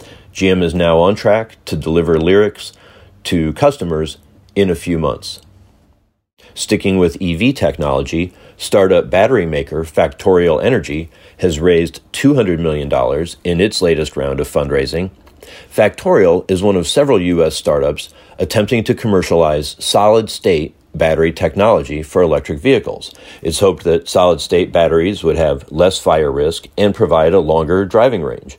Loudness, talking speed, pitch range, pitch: -14 LUFS, 140 wpm, 80-100 Hz, 90 Hz